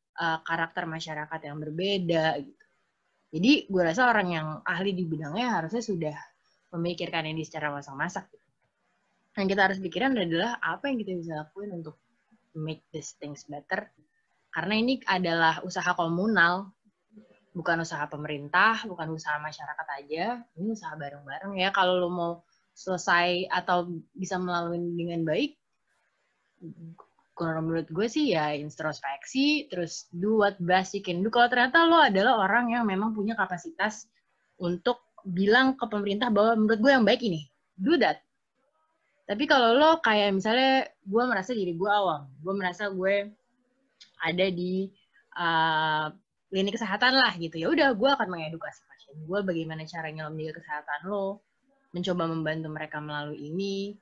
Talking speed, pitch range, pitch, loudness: 145 wpm, 160-220 Hz, 185 Hz, -27 LUFS